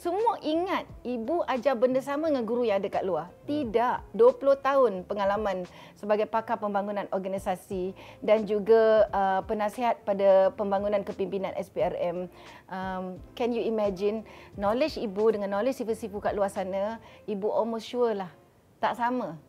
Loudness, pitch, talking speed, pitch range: -28 LUFS, 215 Hz, 140 wpm, 195-245 Hz